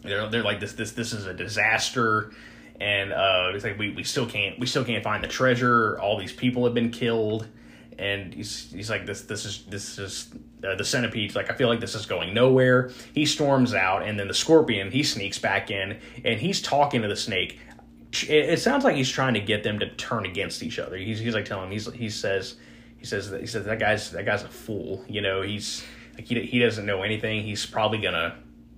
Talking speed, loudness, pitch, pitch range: 230 wpm, -25 LUFS, 110 Hz, 100-120 Hz